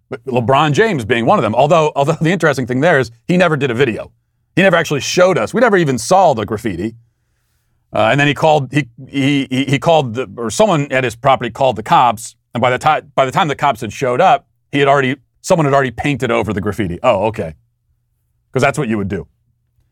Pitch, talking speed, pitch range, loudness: 130 Hz, 235 wpm, 115-145 Hz, -14 LUFS